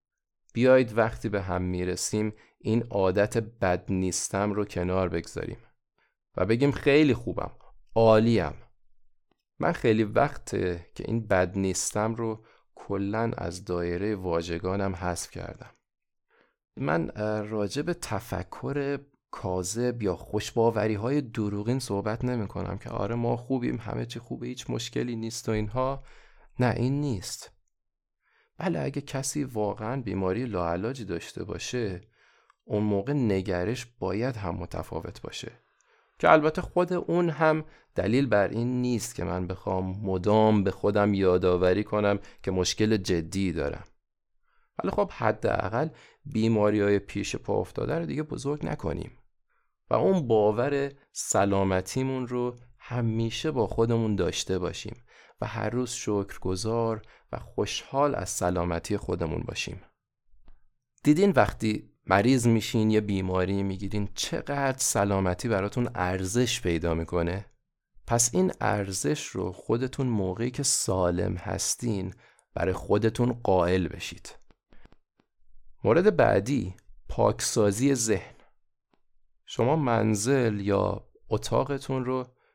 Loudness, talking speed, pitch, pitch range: -27 LUFS, 120 wpm, 105 Hz, 95-125 Hz